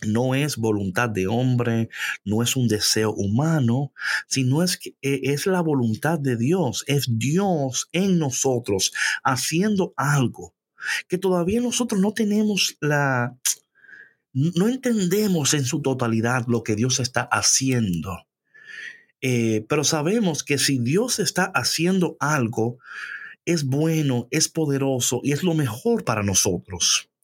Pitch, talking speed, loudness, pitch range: 140 Hz, 130 wpm, -22 LUFS, 120-175 Hz